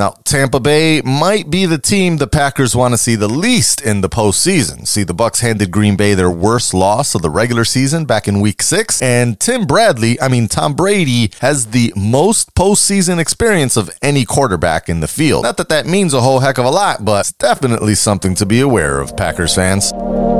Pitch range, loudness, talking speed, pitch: 105-145 Hz, -13 LUFS, 210 wpm, 120 Hz